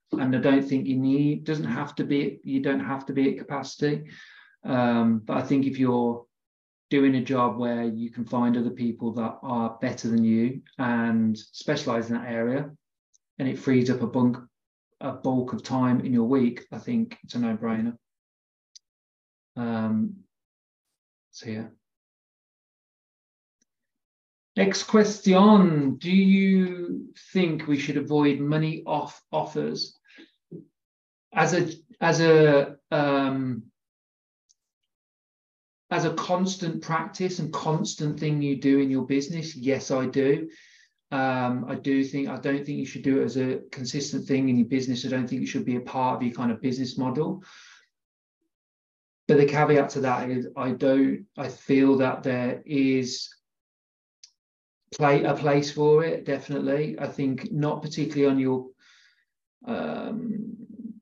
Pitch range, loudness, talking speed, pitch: 120-150 Hz, -25 LUFS, 150 wpm, 135 Hz